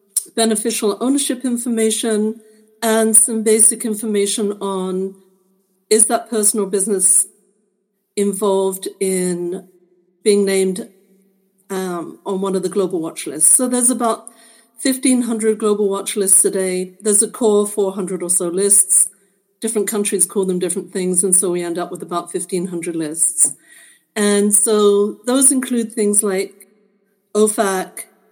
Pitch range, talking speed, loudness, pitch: 190-220 Hz, 130 wpm, -16 LUFS, 200 Hz